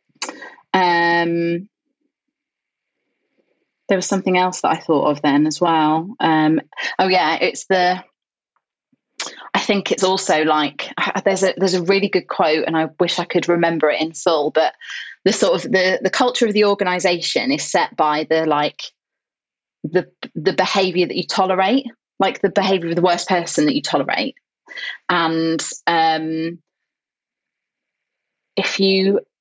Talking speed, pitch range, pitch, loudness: 150 wpm, 165-195 Hz, 185 Hz, -18 LUFS